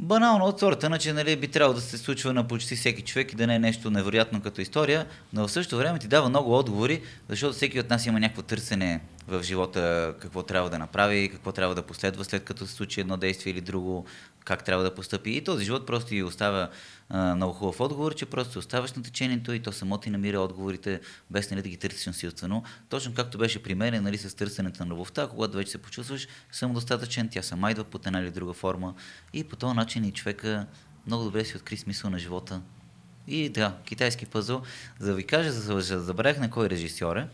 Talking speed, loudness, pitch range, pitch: 220 wpm, -28 LUFS, 95-125 Hz, 105 Hz